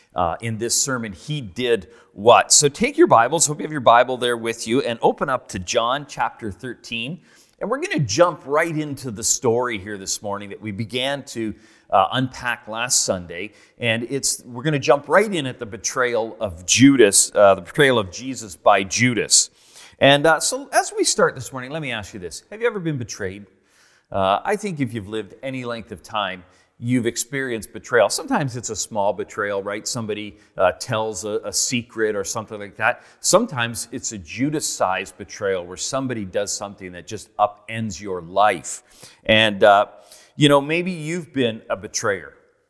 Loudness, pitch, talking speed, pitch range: -20 LUFS, 120 Hz, 195 wpm, 105-145 Hz